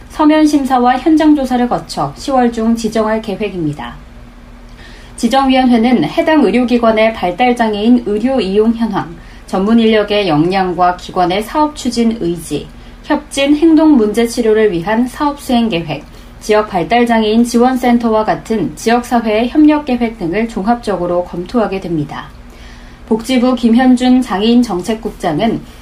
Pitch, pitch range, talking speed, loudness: 225 Hz, 195-250 Hz, 305 characters per minute, -12 LUFS